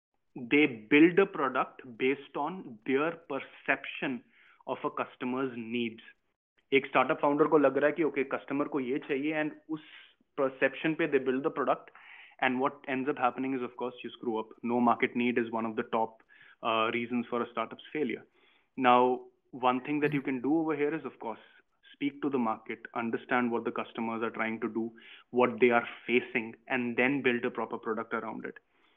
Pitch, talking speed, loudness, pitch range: 125 Hz, 190 wpm, -31 LUFS, 120-145 Hz